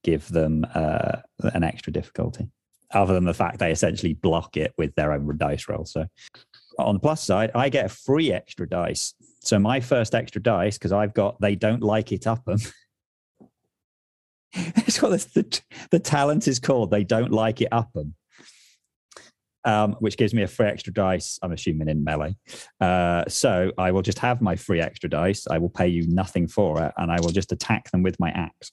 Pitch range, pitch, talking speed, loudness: 85-110 Hz, 100 Hz, 200 wpm, -24 LUFS